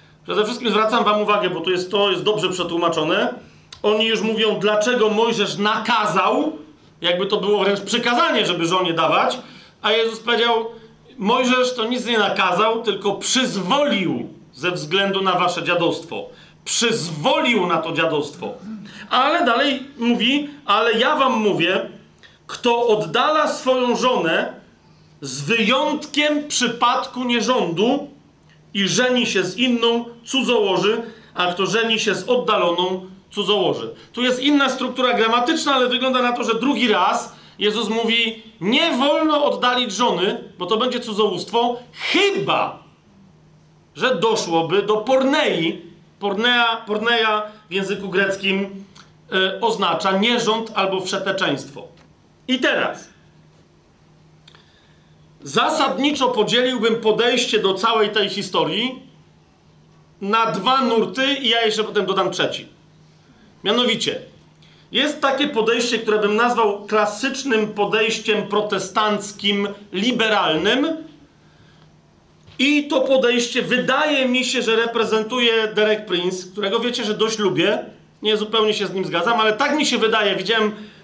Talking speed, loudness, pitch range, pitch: 125 wpm, -19 LUFS, 195-245 Hz, 220 Hz